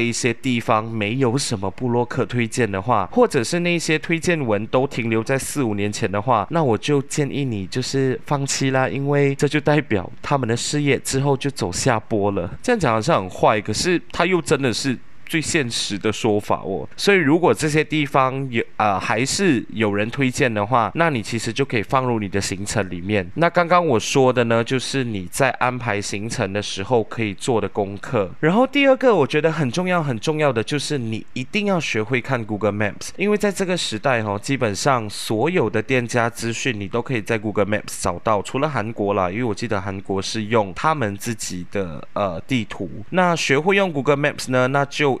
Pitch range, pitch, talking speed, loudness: 105-145 Hz, 125 Hz, 330 characters per minute, -20 LUFS